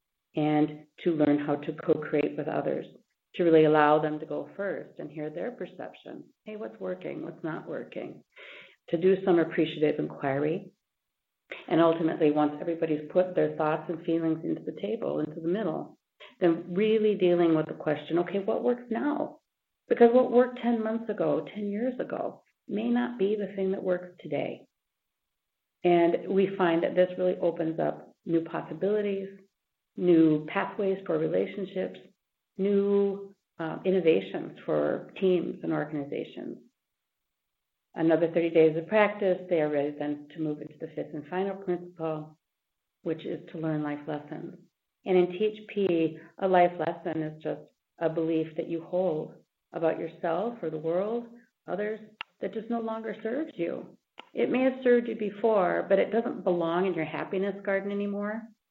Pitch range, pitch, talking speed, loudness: 160-205 Hz, 175 Hz, 160 wpm, -28 LUFS